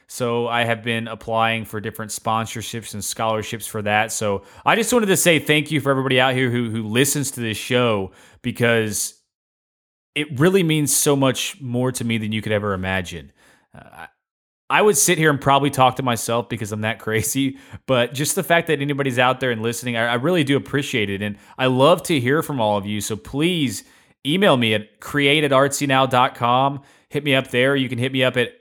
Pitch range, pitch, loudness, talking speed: 110-140 Hz, 125 Hz, -19 LUFS, 210 wpm